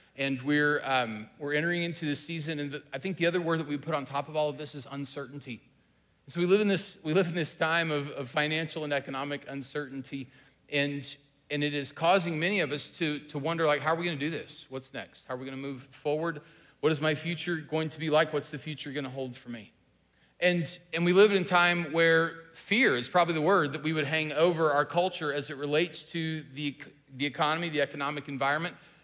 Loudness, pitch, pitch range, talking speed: -29 LUFS, 150 Hz, 140-165 Hz, 240 wpm